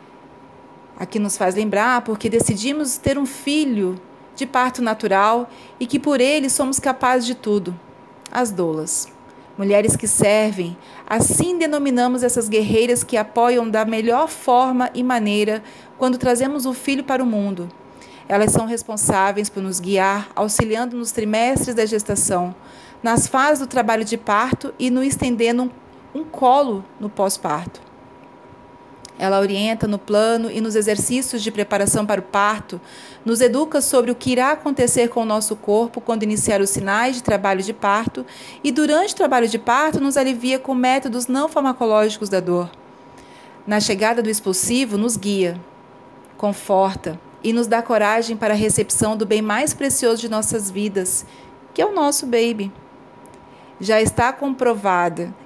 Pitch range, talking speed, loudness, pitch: 205-250 Hz, 155 wpm, -19 LUFS, 225 Hz